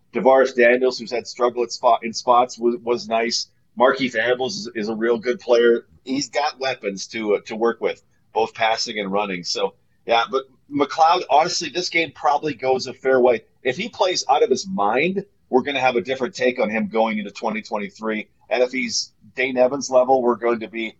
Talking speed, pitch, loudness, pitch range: 195 wpm, 120 Hz, -21 LUFS, 115-130 Hz